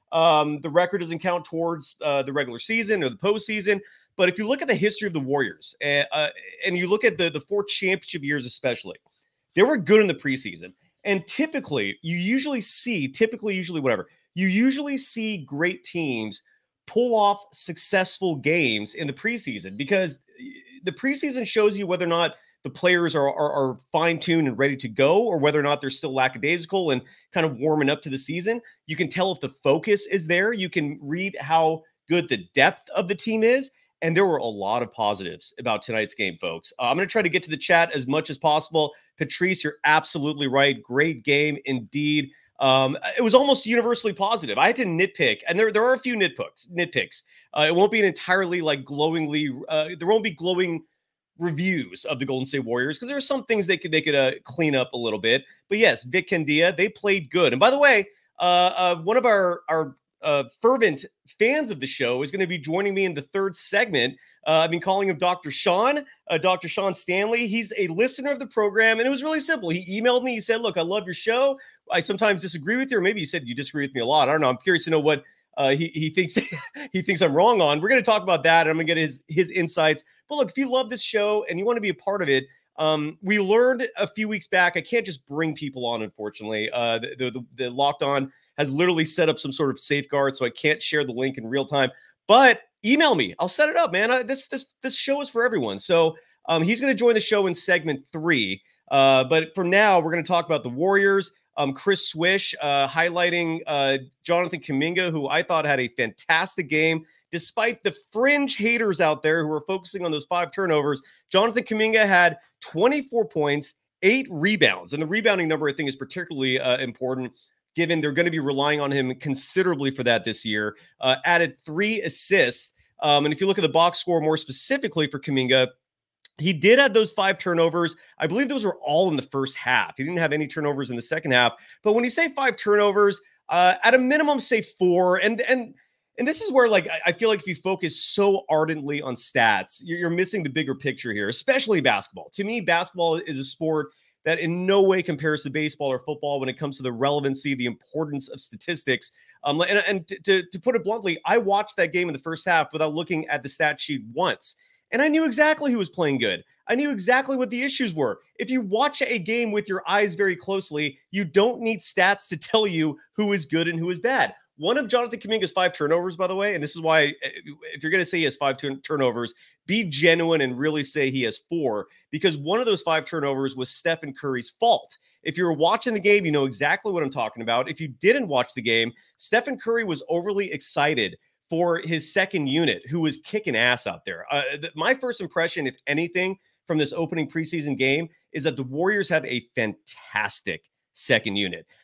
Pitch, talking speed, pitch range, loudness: 170 Hz, 225 wpm, 145-205 Hz, -23 LUFS